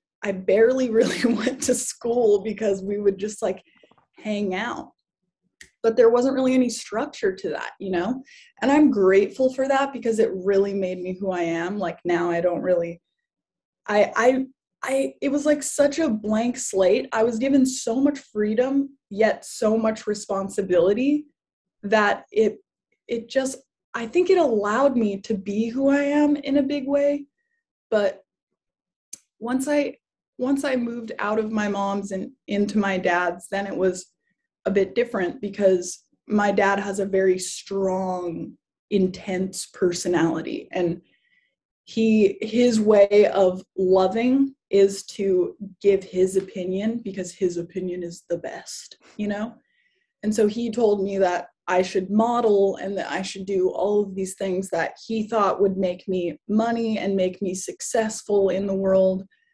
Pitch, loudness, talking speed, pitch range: 205 Hz, -23 LUFS, 160 wpm, 190-245 Hz